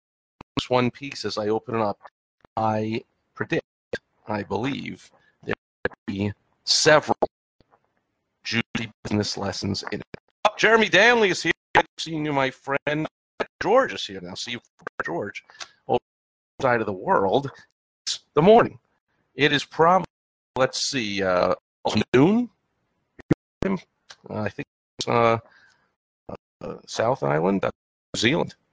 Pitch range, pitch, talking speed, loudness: 105-135 Hz, 115 Hz, 130 wpm, -23 LUFS